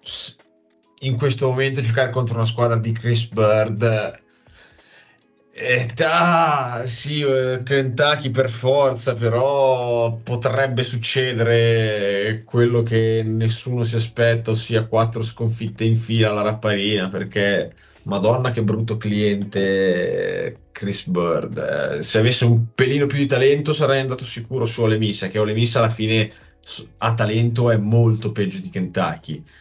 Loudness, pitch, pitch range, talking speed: -20 LUFS, 115 Hz, 110-130 Hz, 130 wpm